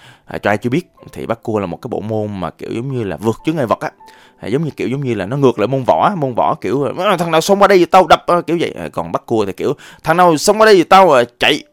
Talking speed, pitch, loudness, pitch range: 310 wpm, 160 Hz, -14 LUFS, 115-185 Hz